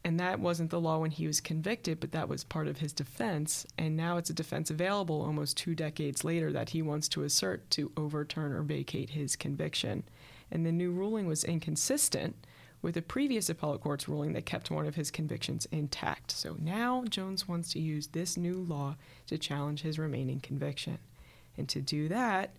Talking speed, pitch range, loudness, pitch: 195 wpm, 145-170 Hz, -34 LUFS, 155 Hz